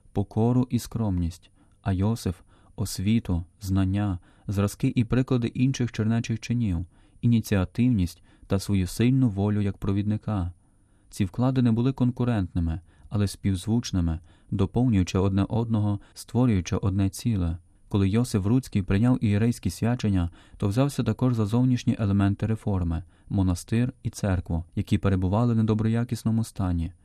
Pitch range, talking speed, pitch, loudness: 95-115 Hz, 120 wpm, 105 Hz, -26 LUFS